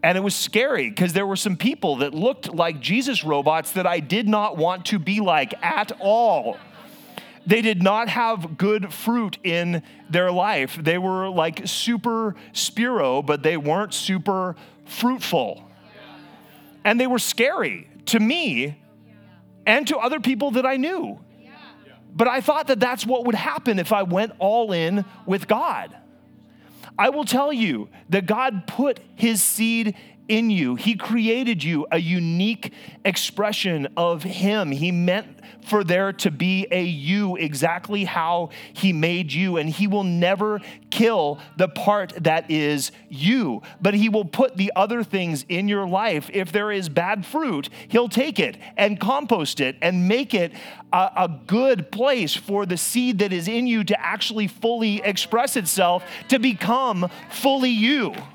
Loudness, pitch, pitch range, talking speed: -22 LUFS, 200 Hz, 175-230 Hz, 160 wpm